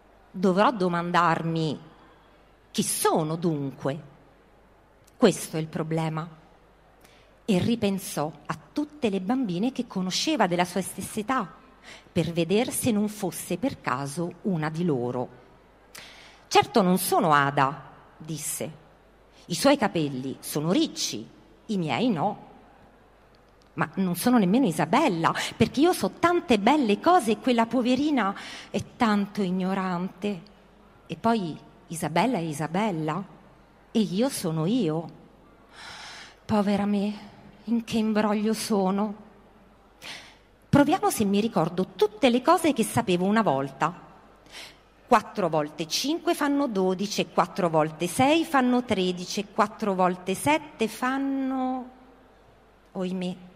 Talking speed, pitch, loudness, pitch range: 115 wpm, 200 Hz, -25 LUFS, 170-235 Hz